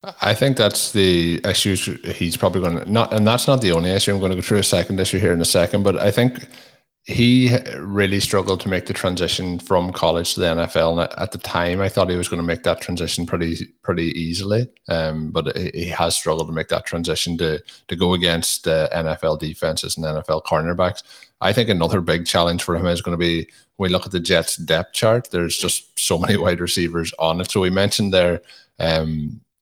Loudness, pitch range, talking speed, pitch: -19 LUFS, 85-100 Hz, 225 wpm, 90 Hz